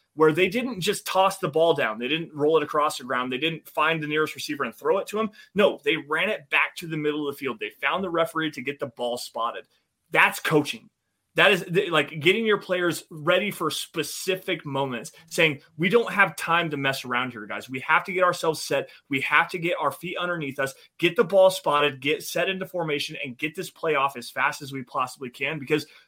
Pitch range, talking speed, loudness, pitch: 145-180 Hz, 235 wpm, -24 LUFS, 160 Hz